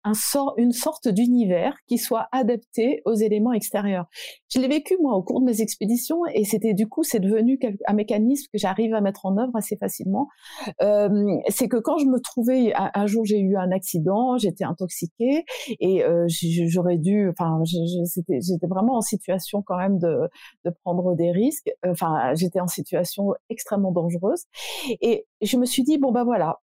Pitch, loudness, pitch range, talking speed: 210 Hz, -23 LUFS, 185-250 Hz, 180 wpm